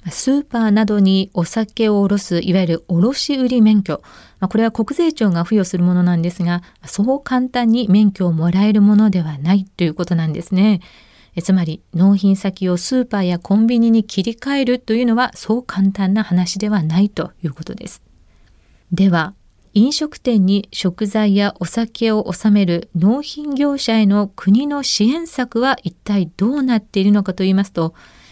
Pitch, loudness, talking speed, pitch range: 200 Hz, -16 LUFS, 330 characters per minute, 180-225 Hz